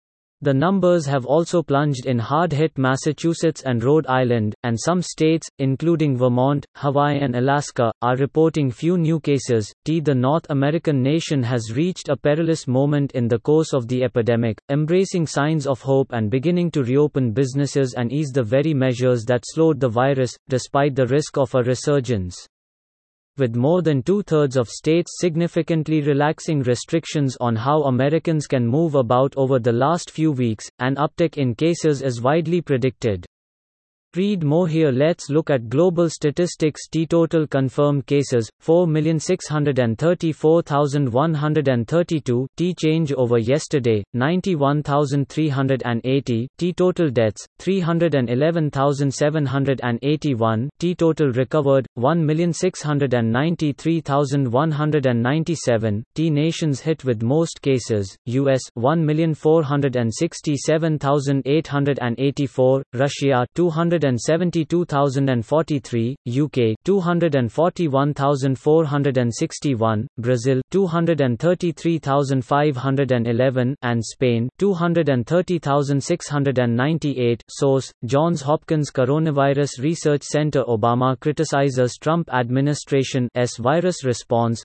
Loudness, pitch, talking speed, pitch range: -20 LUFS, 140 Hz, 105 wpm, 130-160 Hz